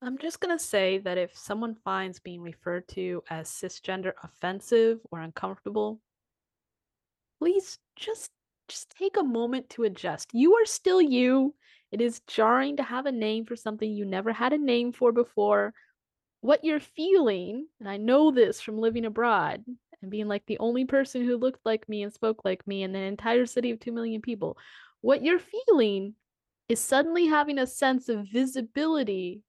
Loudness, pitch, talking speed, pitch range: -27 LUFS, 235 Hz, 175 wpm, 205-275 Hz